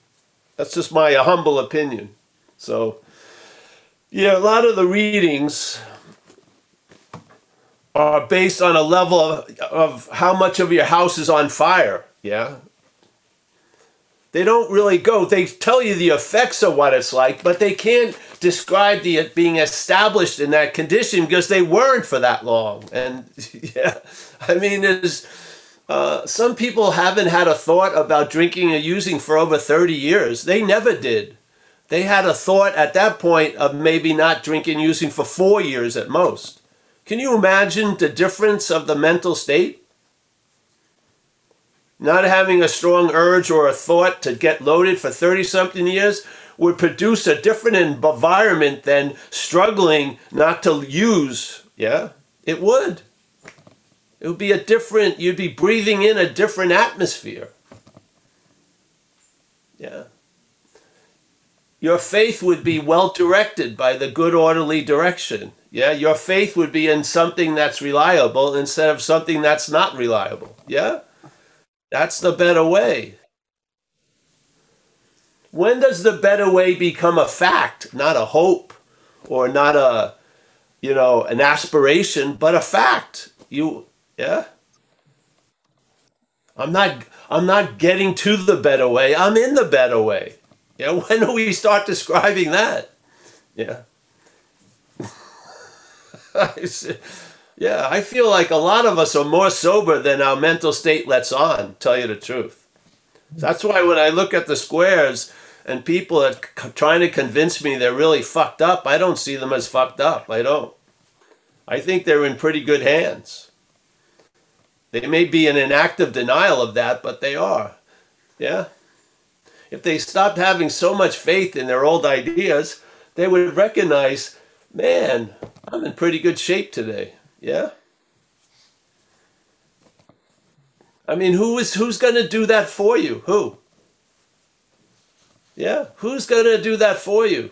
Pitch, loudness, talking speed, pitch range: 175 Hz, -17 LUFS, 145 wpm, 155-200 Hz